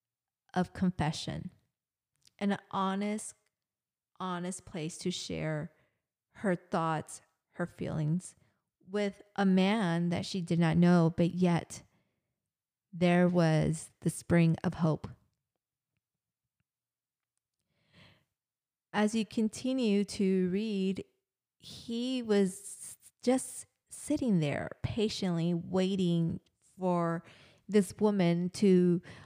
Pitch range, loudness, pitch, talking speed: 165-200 Hz, -31 LUFS, 180 Hz, 90 wpm